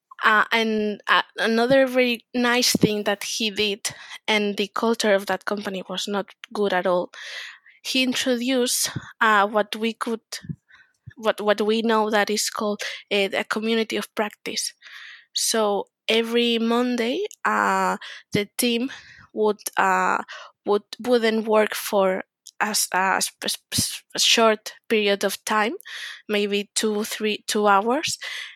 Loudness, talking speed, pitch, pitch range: -22 LUFS, 130 wpm, 215 Hz, 205-235 Hz